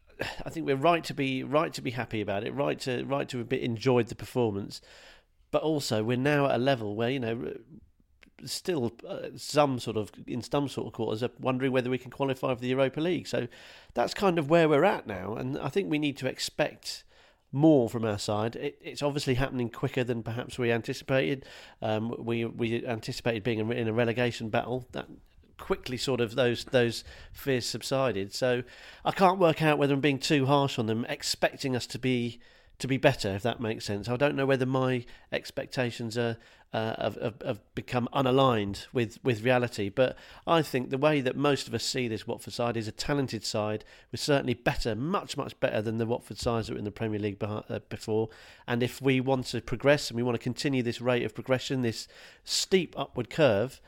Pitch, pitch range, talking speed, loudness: 125 Hz, 115-135 Hz, 205 wpm, -29 LUFS